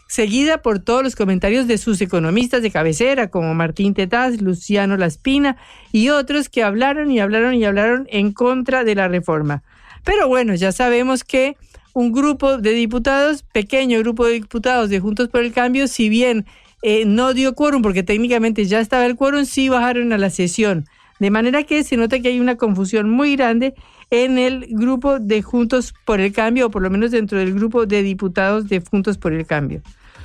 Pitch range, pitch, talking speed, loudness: 205-255 Hz, 230 Hz, 190 wpm, -17 LUFS